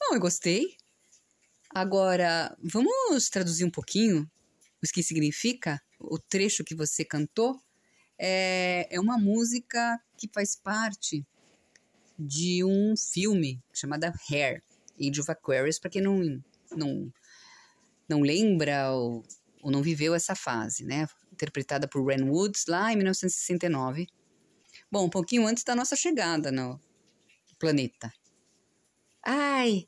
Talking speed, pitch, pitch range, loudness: 125 wpm, 180 Hz, 150-215 Hz, -28 LUFS